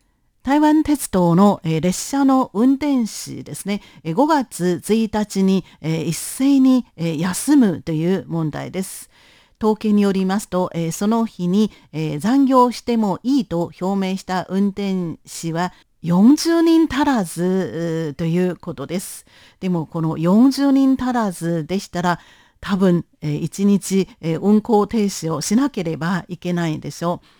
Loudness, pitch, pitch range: -19 LUFS, 190 Hz, 170-230 Hz